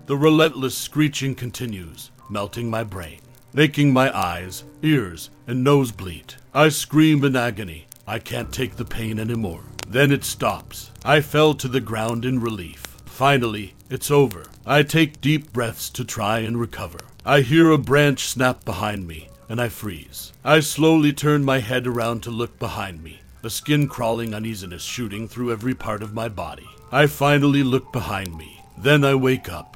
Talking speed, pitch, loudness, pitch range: 170 wpm, 120 Hz, -21 LUFS, 105-140 Hz